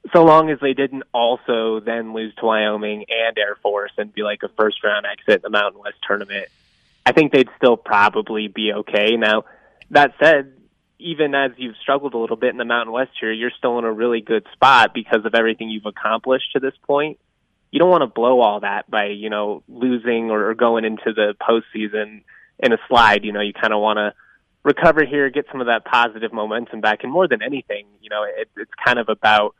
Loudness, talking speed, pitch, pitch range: -18 LUFS, 220 wpm, 115 Hz, 105-130 Hz